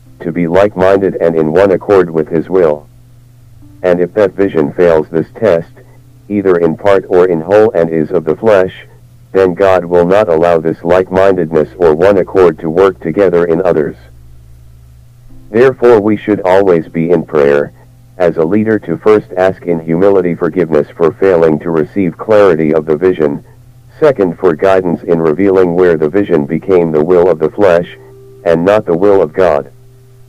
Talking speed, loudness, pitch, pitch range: 175 wpm, -10 LUFS, 95 Hz, 85-110 Hz